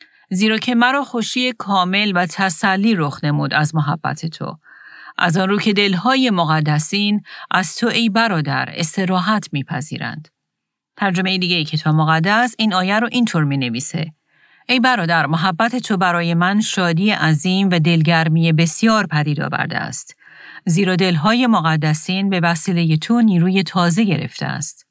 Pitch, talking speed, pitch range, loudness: 185 Hz, 145 wpm, 160-215 Hz, -17 LUFS